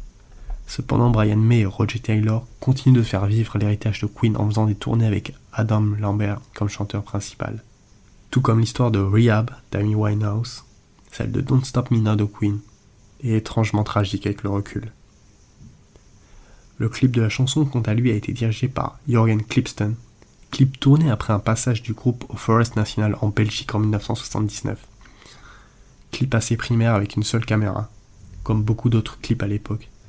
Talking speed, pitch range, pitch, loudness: 170 wpm, 105-120 Hz, 110 Hz, -21 LUFS